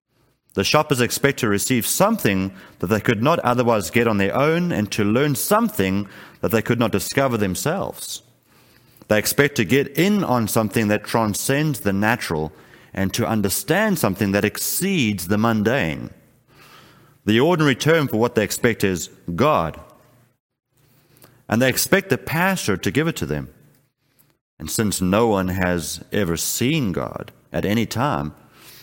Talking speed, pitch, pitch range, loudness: 155 wpm, 115 Hz, 100-135 Hz, -20 LUFS